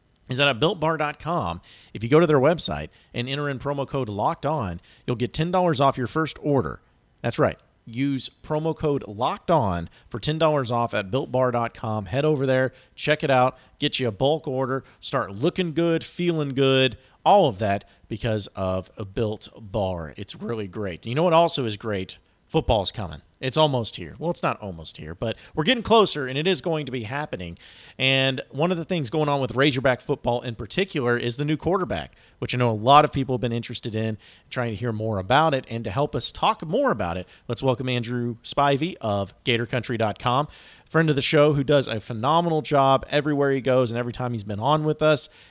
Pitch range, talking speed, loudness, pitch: 115-150 Hz, 205 wpm, -24 LUFS, 130 Hz